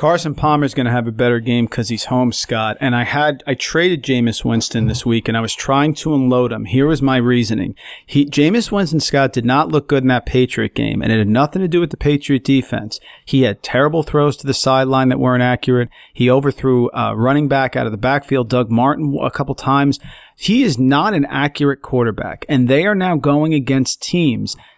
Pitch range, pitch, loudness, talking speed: 120-145 Hz, 130 Hz, -16 LUFS, 225 wpm